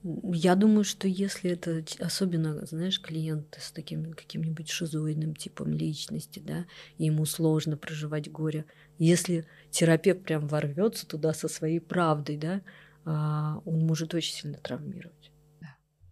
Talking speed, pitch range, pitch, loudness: 125 wpm, 155-175 Hz, 160 Hz, -29 LUFS